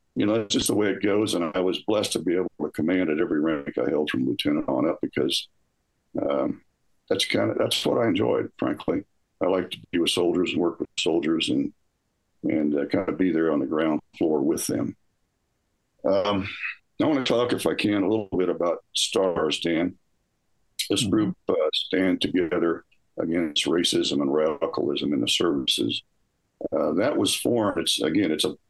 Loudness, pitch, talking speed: -25 LUFS, 330 Hz, 195 wpm